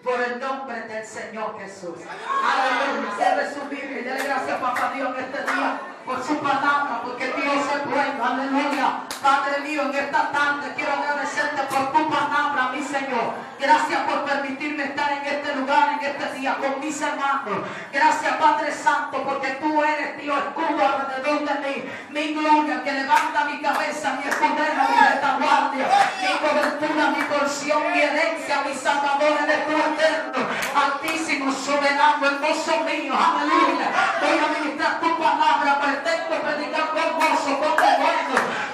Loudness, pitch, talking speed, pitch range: -22 LUFS, 285 Hz, 155 wpm, 275-300 Hz